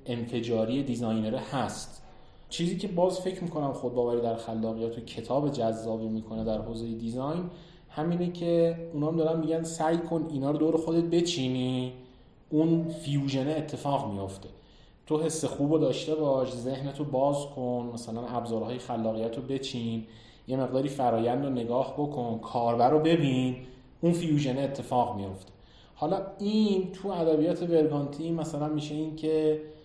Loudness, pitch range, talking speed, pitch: -29 LUFS, 120-160 Hz, 145 wpm, 135 Hz